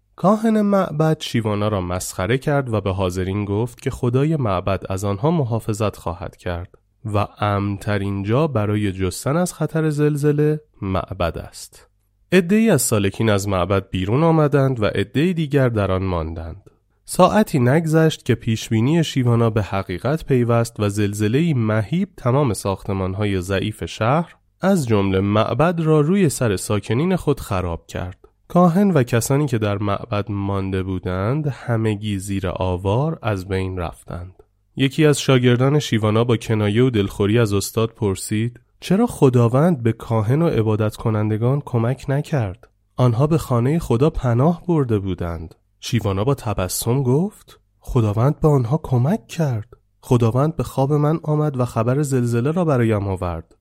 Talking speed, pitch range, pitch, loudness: 140 wpm, 100-145 Hz, 115 Hz, -20 LUFS